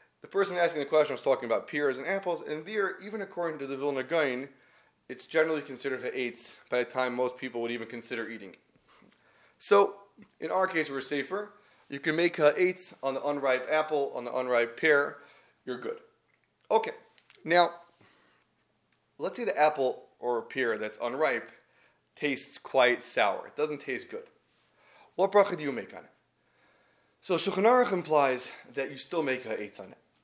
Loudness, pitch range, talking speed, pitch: -29 LUFS, 130-195 Hz, 180 wpm, 155 Hz